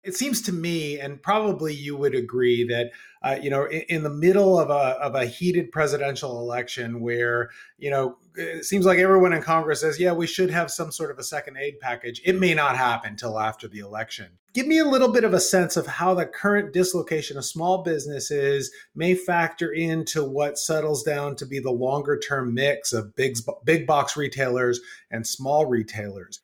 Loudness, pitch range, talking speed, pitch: -23 LUFS, 130-175 Hz, 200 wpm, 145 Hz